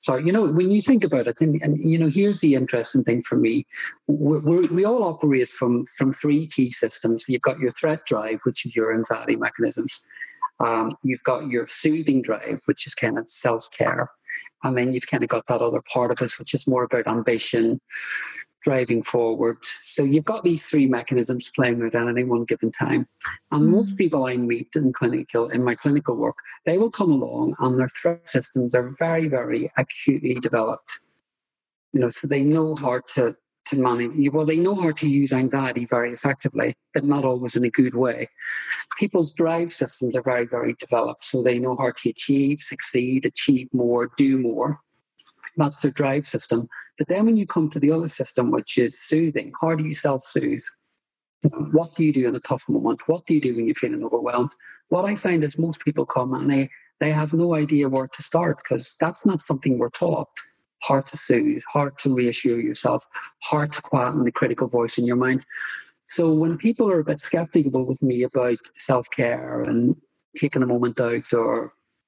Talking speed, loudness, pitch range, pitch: 200 wpm, -22 LUFS, 125-160 Hz, 140 Hz